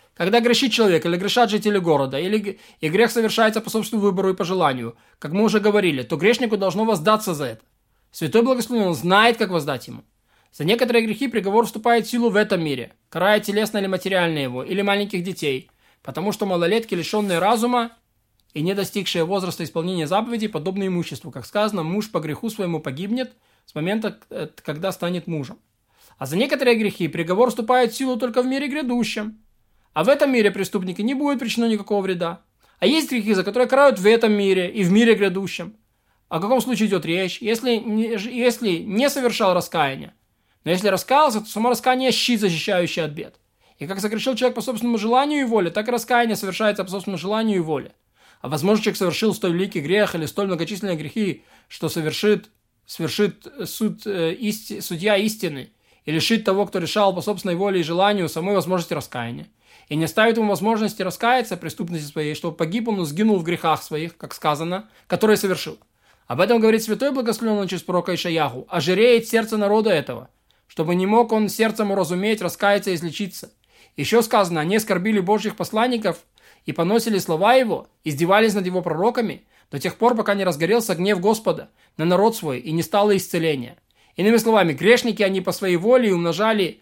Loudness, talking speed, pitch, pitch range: -21 LUFS, 180 wpm, 200 Hz, 170-225 Hz